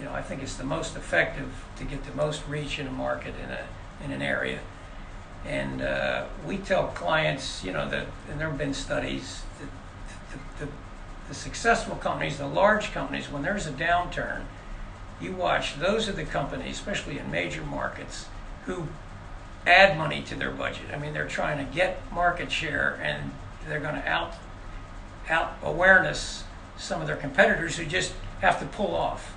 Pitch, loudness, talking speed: 95 Hz, -27 LUFS, 180 wpm